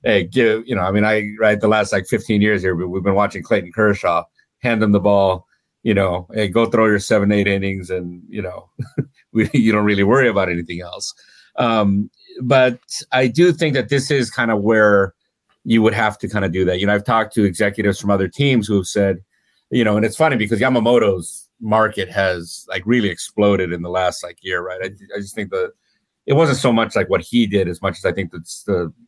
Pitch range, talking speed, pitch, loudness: 95-115 Hz, 230 wpm, 105 Hz, -17 LUFS